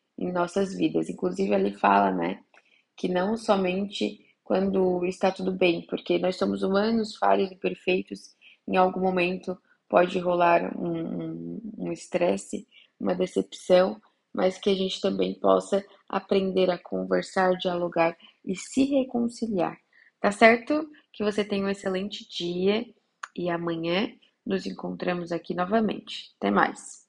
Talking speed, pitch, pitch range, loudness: 135 wpm, 185 Hz, 175-200 Hz, -26 LUFS